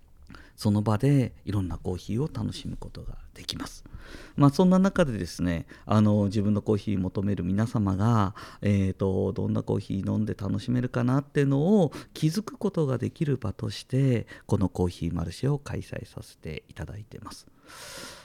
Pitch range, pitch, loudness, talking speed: 95-130 Hz, 105 Hz, -27 LUFS, 295 characters per minute